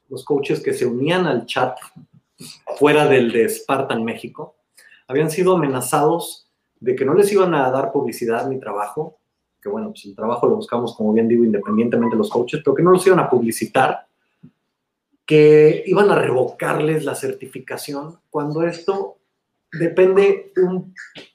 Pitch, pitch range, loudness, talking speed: 155 Hz, 130-190 Hz, -18 LUFS, 155 wpm